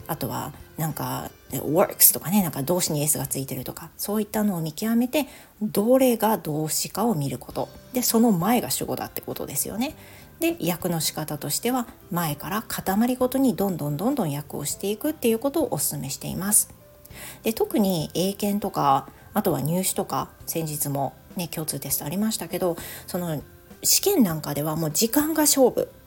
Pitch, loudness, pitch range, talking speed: 190 Hz, -24 LUFS, 155-235 Hz, 365 characters per minute